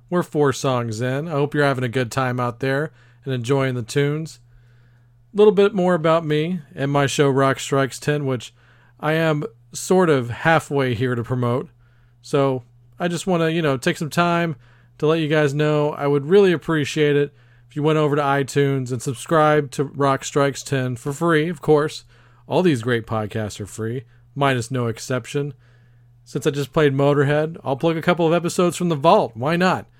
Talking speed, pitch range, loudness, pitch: 200 wpm, 125-155 Hz, -20 LUFS, 140 Hz